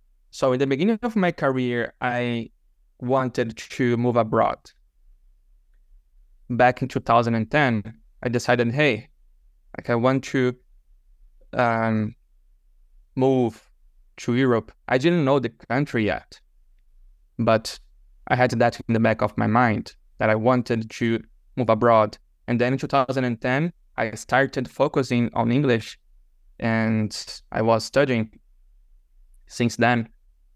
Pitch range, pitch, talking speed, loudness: 105-125 Hz, 115 Hz, 125 wpm, -23 LUFS